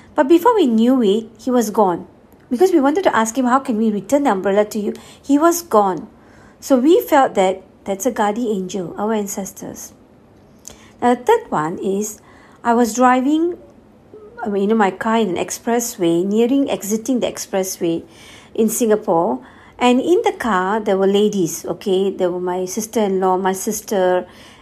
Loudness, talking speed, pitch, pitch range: -17 LUFS, 170 wpm, 220 Hz, 195-255 Hz